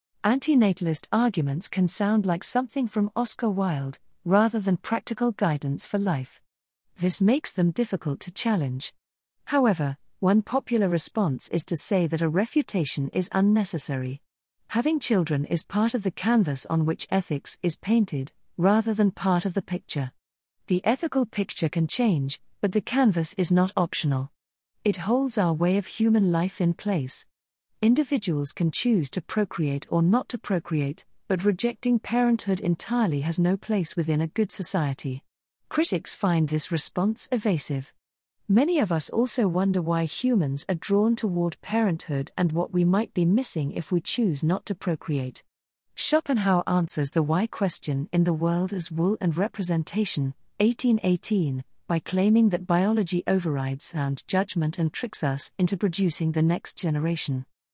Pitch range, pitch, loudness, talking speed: 160-215 Hz, 180 Hz, -25 LUFS, 155 wpm